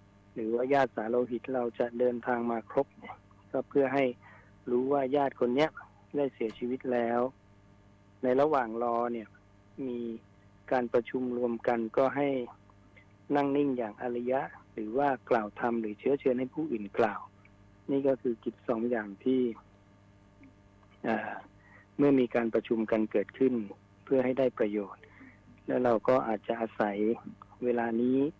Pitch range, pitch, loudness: 100-130 Hz, 120 Hz, -31 LUFS